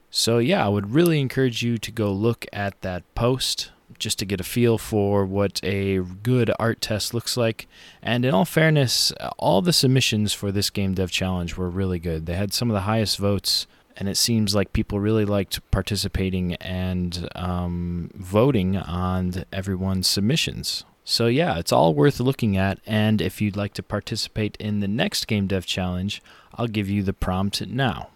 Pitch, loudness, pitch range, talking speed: 100 Hz, -23 LUFS, 95-115 Hz, 185 wpm